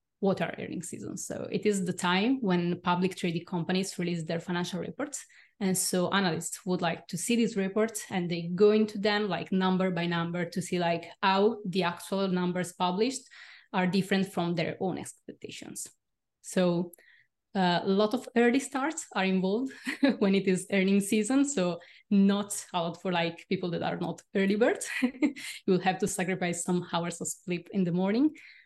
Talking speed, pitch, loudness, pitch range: 180 wpm, 185 Hz, -29 LUFS, 175-210 Hz